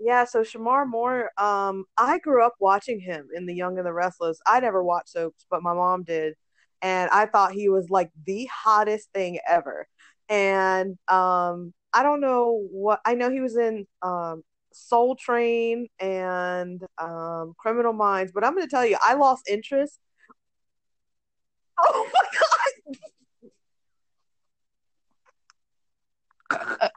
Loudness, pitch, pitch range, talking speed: -24 LUFS, 200 Hz, 180-235 Hz, 145 wpm